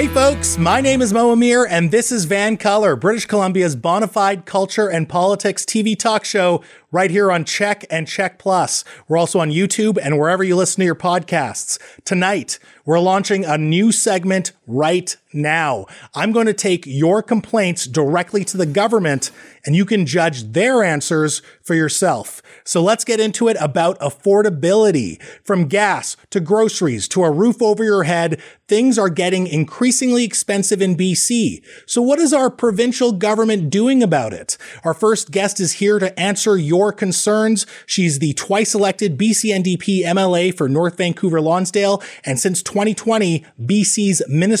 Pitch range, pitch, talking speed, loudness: 170-215 Hz, 195 Hz, 165 wpm, -16 LUFS